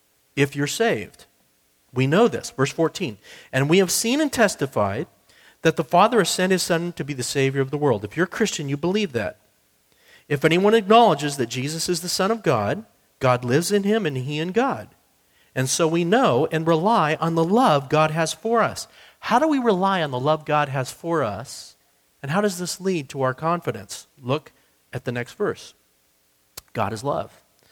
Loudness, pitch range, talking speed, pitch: -22 LUFS, 135-190 Hz, 200 wpm, 160 Hz